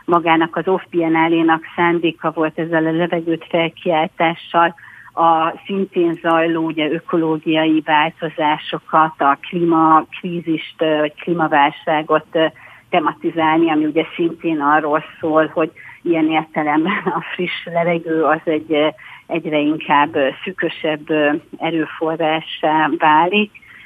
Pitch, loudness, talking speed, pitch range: 160 Hz, -17 LUFS, 100 wpm, 155-170 Hz